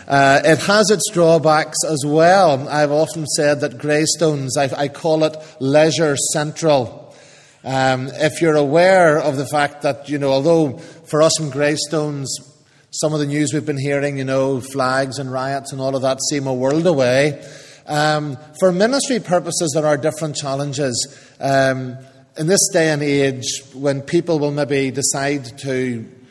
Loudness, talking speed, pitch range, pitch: -17 LUFS, 165 wpm, 135-155 Hz, 145 Hz